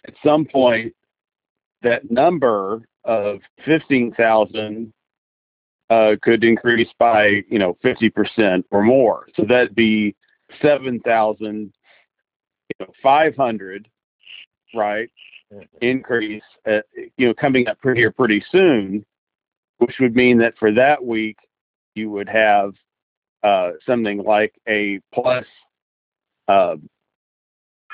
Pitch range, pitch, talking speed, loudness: 105-125 Hz, 110 Hz, 105 wpm, -17 LUFS